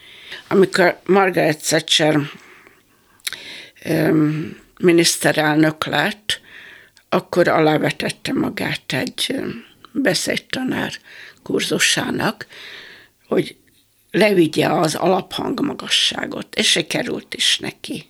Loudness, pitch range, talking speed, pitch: -18 LUFS, 155-190 Hz, 70 wpm, 160 Hz